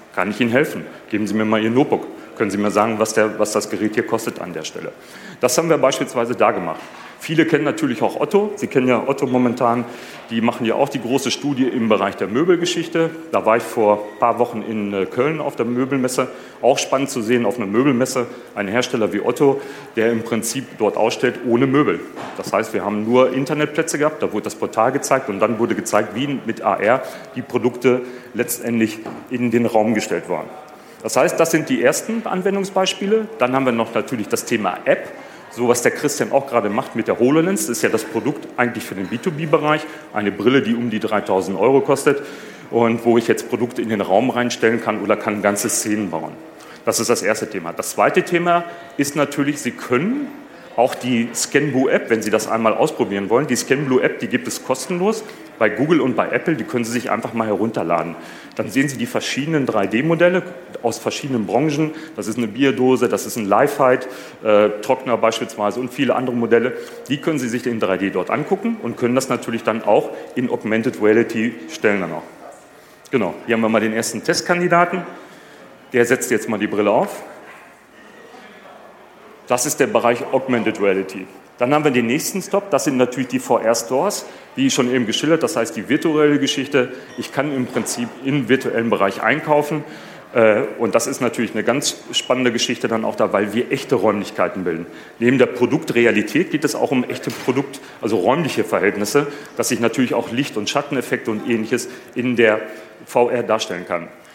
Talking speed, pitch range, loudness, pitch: 195 wpm, 110-145 Hz, -19 LUFS, 125 Hz